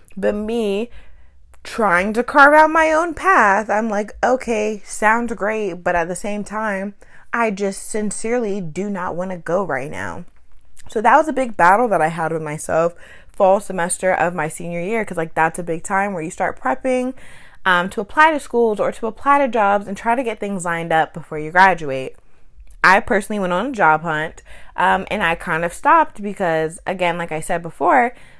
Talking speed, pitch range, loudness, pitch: 200 wpm, 165-220 Hz, -18 LUFS, 195 Hz